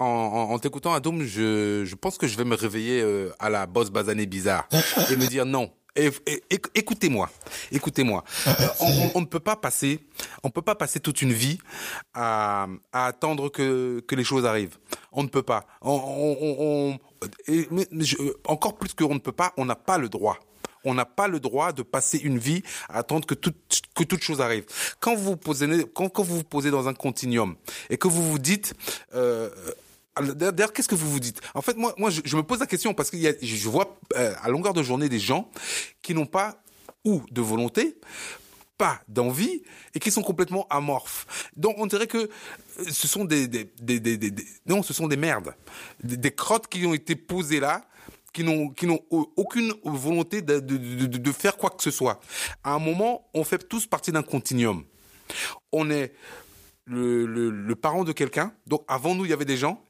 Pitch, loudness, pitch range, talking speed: 150 Hz, -26 LUFS, 125-180 Hz, 200 wpm